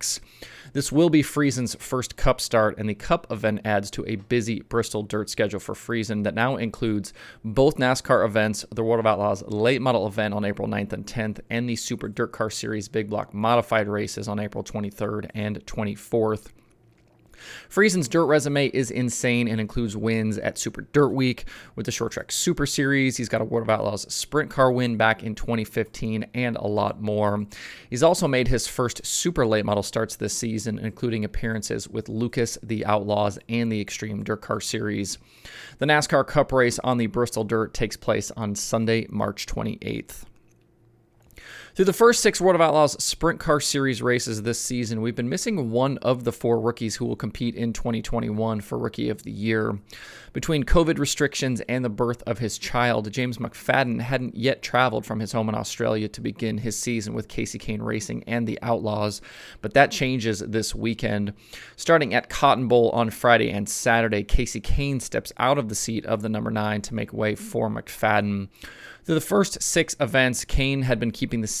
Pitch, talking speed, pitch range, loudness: 115 Hz, 190 wpm, 105-125 Hz, -24 LUFS